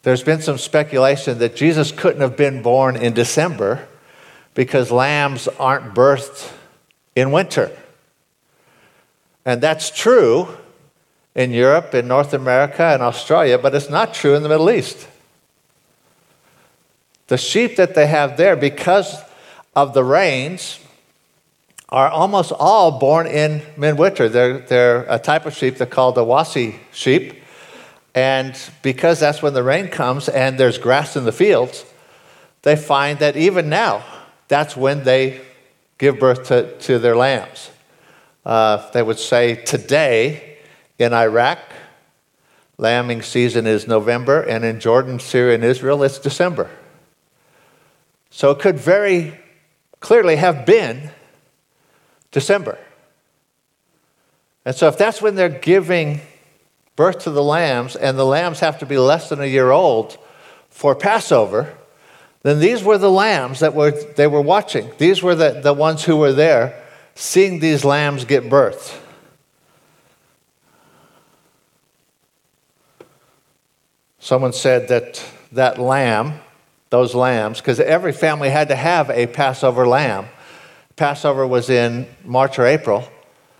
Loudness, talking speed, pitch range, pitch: -16 LUFS, 135 wpm, 130-160 Hz, 140 Hz